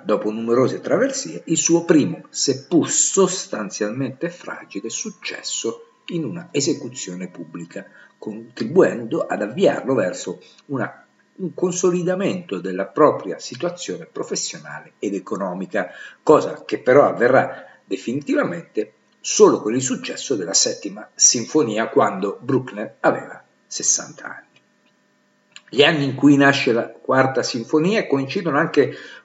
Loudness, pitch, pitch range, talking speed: -20 LUFS, 160 Hz, 125-185 Hz, 110 wpm